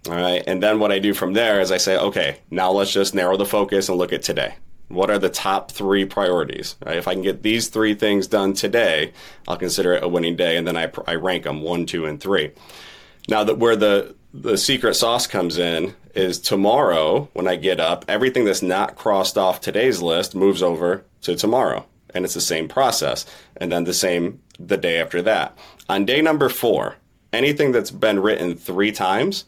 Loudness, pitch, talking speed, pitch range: -20 LUFS, 95 Hz, 215 wpm, 90-105 Hz